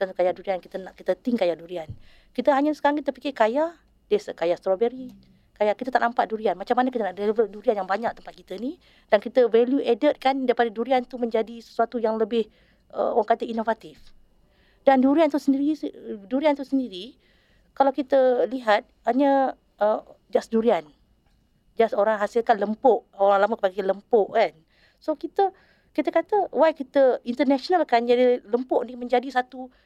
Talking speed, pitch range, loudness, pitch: 170 wpm, 210-270 Hz, -23 LUFS, 240 Hz